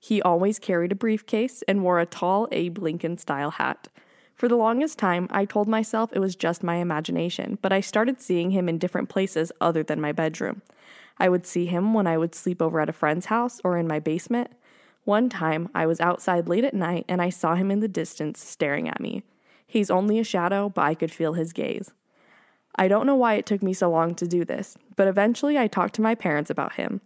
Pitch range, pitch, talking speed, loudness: 170-215 Hz, 185 Hz, 230 wpm, -25 LUFS